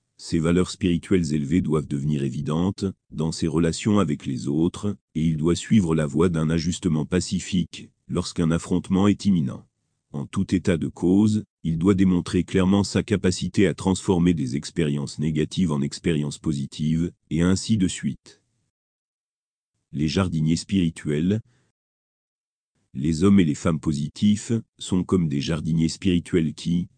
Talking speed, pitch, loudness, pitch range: 140 wpm, 85 Hz, -23 LUFS, 80-95 Hz